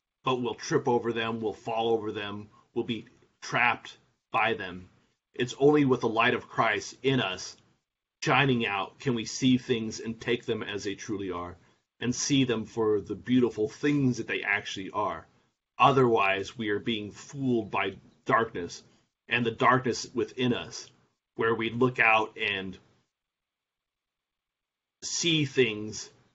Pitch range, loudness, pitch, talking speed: 105-130 Hz, -28 LUFS, 115 Hz, 150 wpm